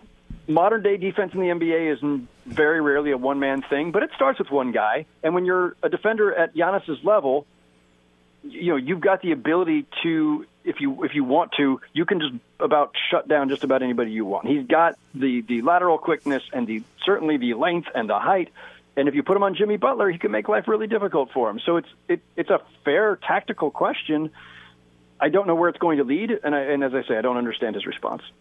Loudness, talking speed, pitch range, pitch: -22 LUFS, 230 wpm, 135-195 Hz, 155 Hz